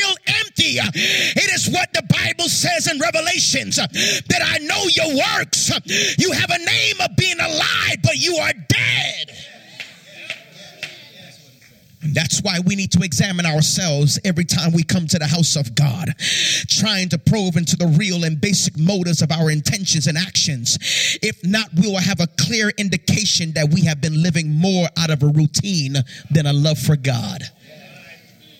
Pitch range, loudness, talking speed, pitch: 155-185 Hz, -17 LUFS, 165 wpm, 165 Hz